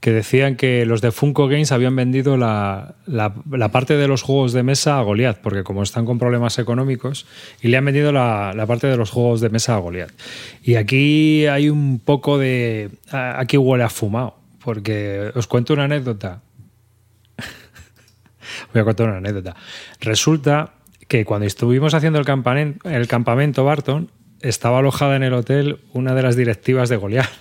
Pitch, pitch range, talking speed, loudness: 125 Hz, 115-140 Hz, 175 wpm, -18 LUFS